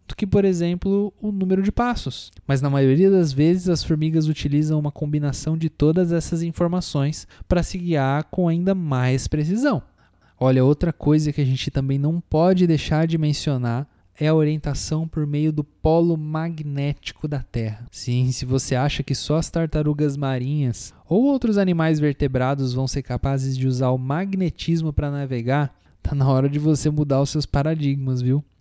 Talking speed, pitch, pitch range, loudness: 170 wpm, 150 Hz, 135-165 Hz, -21 LUFS